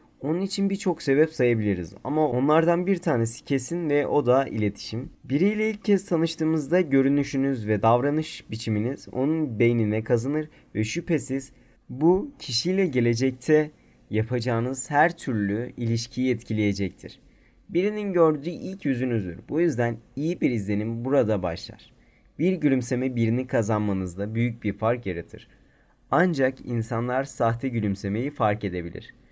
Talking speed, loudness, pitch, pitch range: 125 wpm, -25 LUFS, 130 Hz, 115-155 Hz